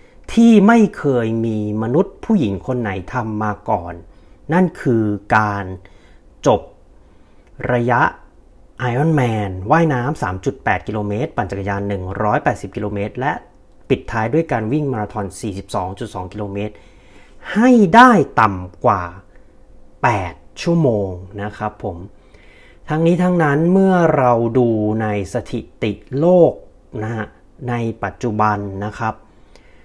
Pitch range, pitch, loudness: 100-145 Hz, 110 Hz, -17 LUFS